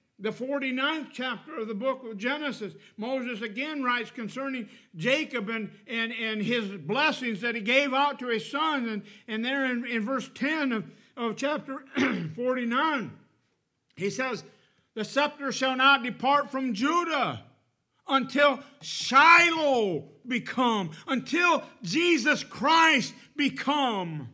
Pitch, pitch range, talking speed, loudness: 255 Hz, 230-280 Hz, 130 wpm, -26 LUFS